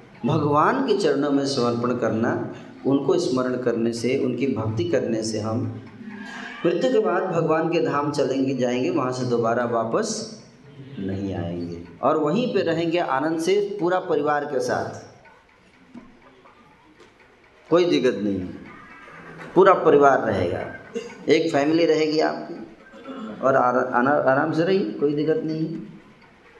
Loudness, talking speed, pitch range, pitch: -22 LUFS, 135 wpm, 120-165 Hz, 140 Hz